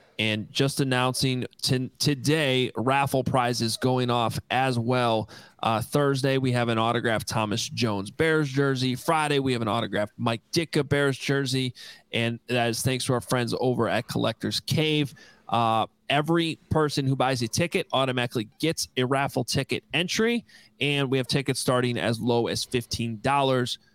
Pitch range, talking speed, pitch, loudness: 115-140 Hz, 160 wpm, 130 Hz, -25 LUFS